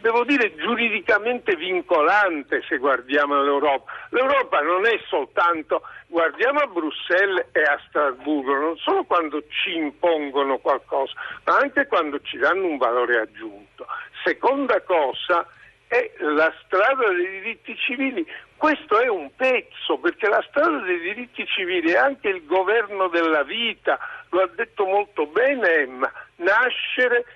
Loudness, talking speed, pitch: -21 LUFS, 135 wpm, 245 Hz